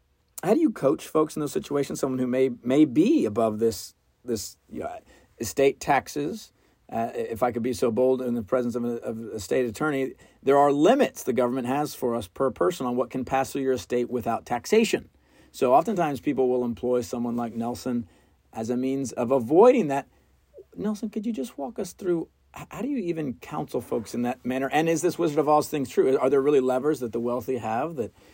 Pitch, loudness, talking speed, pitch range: 130 Hz, -25 LUFS, 215 wpm, 120-145 Hz